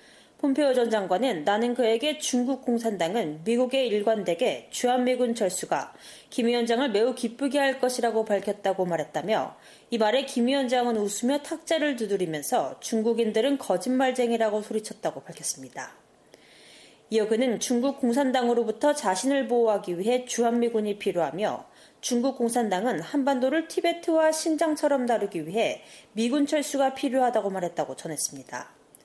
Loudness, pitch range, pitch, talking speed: -26 LUFS, 215-270 Hz, 240 Hz, 350 characters per minute